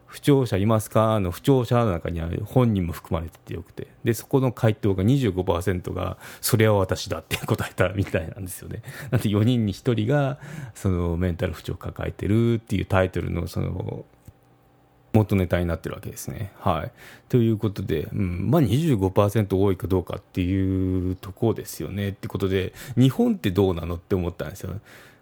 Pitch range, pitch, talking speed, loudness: 95-115 Hz, 100 Hz, 355 characters per minute, -24 LUFS